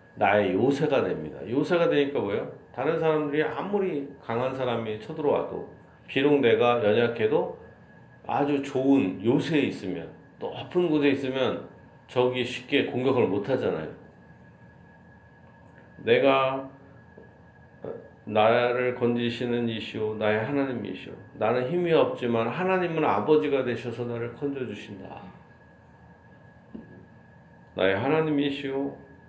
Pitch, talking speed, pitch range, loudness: 130 Hz, 255 characters per minute, 120-145 Hz, -26 LUFS